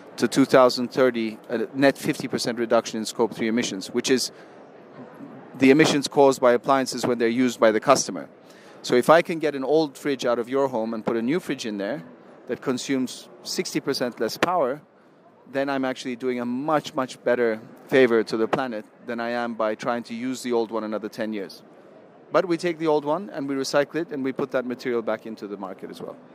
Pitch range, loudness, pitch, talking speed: 115-140 Hz, -23 LUFS, 125 Hz, 210 wpm